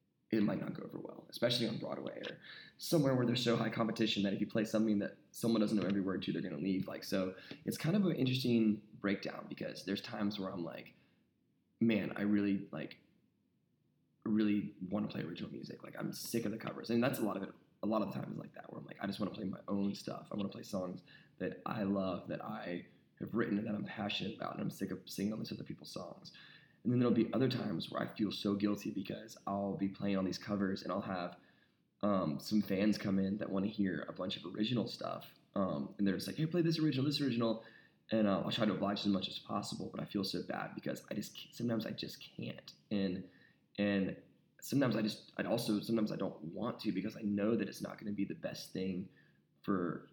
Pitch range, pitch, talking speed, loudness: 100-115 Hz, 105 Hz, 240 wpm, -38 LUFS